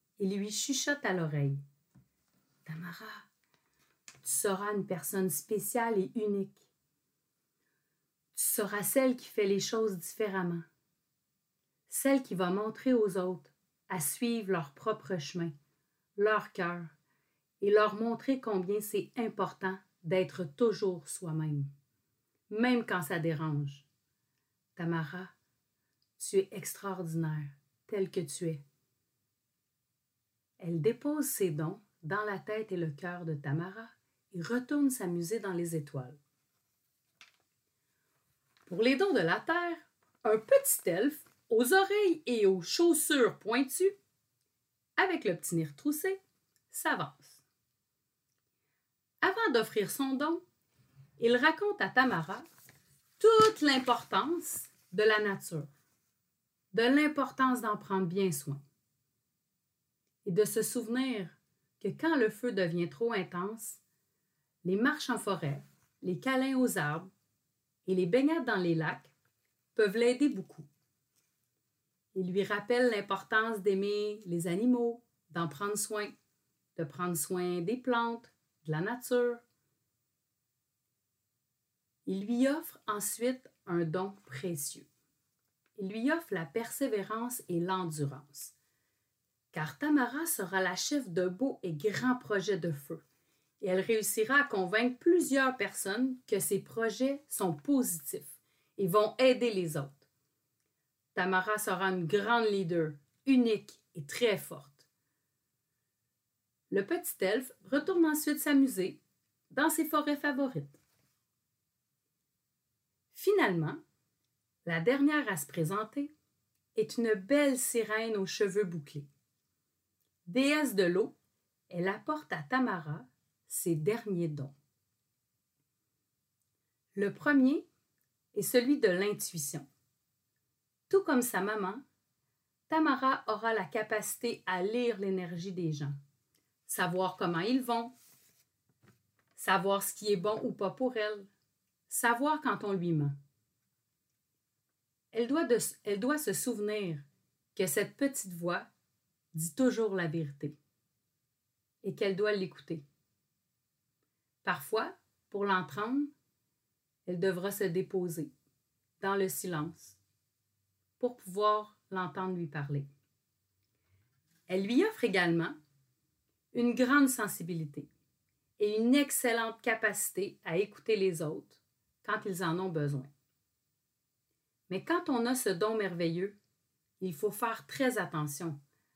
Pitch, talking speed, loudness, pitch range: 190 Hz, 115 wpm, -32 LUFS, 150-230 Hz